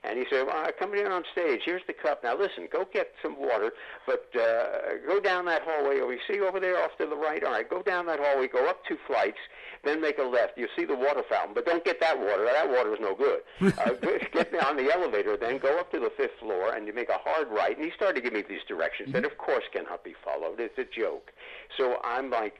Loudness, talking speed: -29 LUFS, 265 wpm